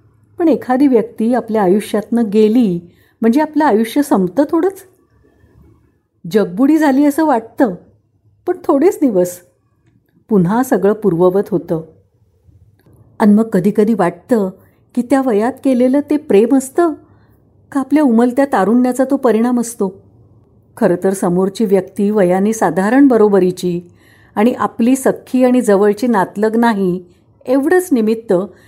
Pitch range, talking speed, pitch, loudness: 185-260 Hz, 120 wpm, 220 Hz, -14 LUFS